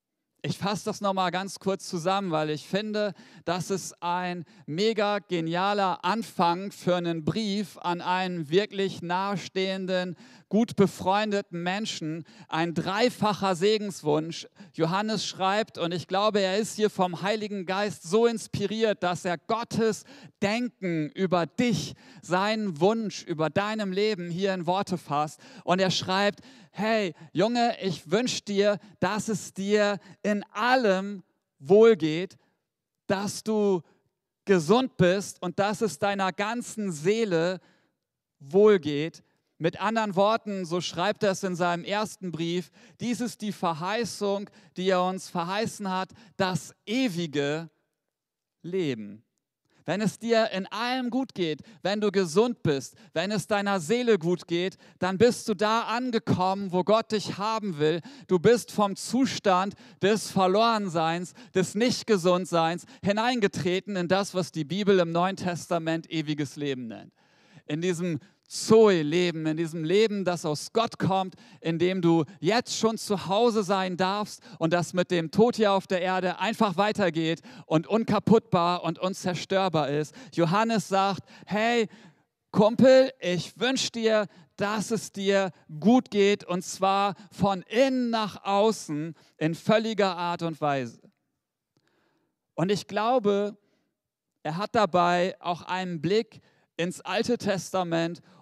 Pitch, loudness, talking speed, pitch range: 190 Hz, -27 LUFS, 135 wpm, 170-210 Hz